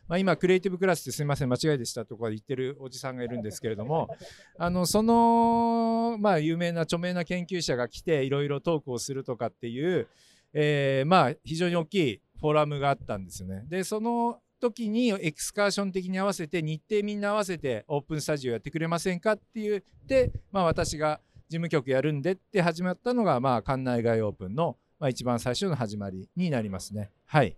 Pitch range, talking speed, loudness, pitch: 125-185 Hz, 410 characters per minute, -28 LUFS, 160 Hz